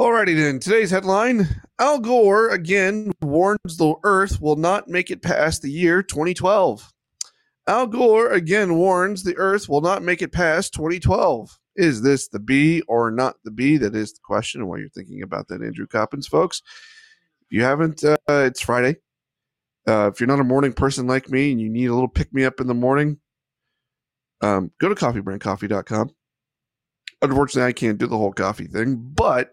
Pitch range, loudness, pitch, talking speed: 125-185 Hz, -20 LUFS, 140 Hz, 185 wpm